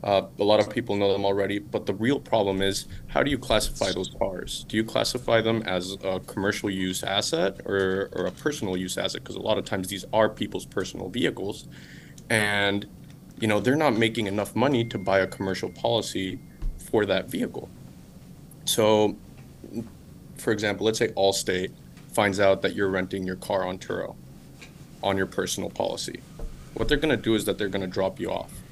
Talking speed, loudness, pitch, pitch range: 190 wpm, -26 LUFS, 100 Hz, 95-110 Hz